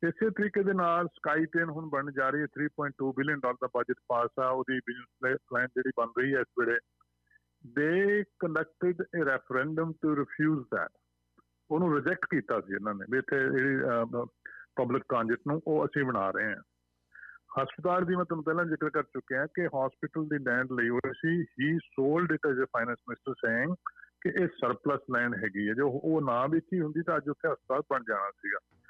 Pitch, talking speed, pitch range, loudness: 145 Hz, 190 wpm, 125-165 Hz, -31 LUFS